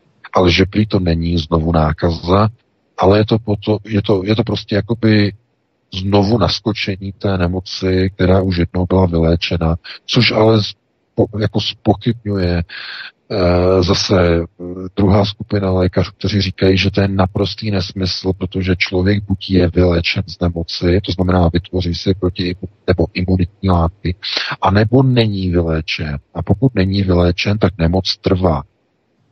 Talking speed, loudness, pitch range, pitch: 140 wpm, -16 LUFS, 90-100 Hz, 95 Hz